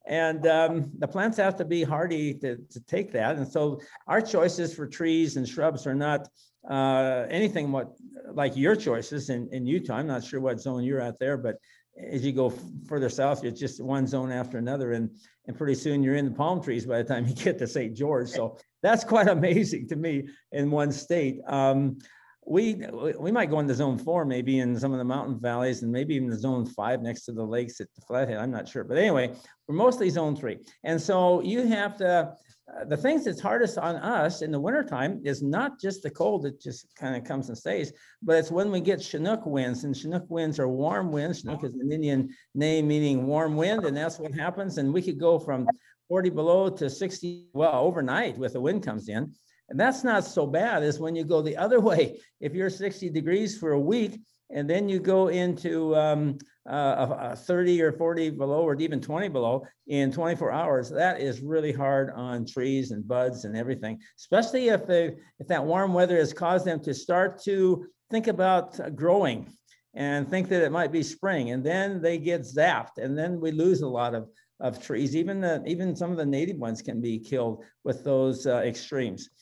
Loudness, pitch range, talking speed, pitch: -27 LUFS, 135-175 Hz, 215 wpm, 150 Hz